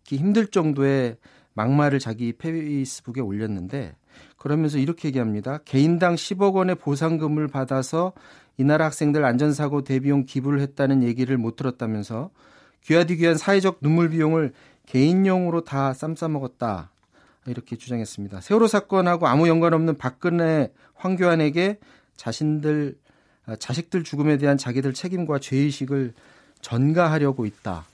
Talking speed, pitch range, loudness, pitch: 335 characters per minute, 130-165 Hz, -22 LUFS, 145 Hz